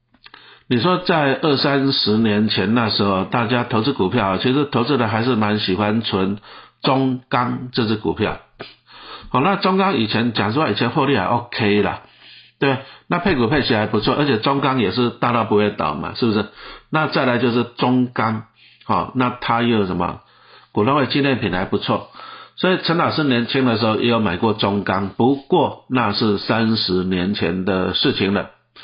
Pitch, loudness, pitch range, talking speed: 120 Hz, -19 LUFS, 105-130 Hz, 265 characters per minute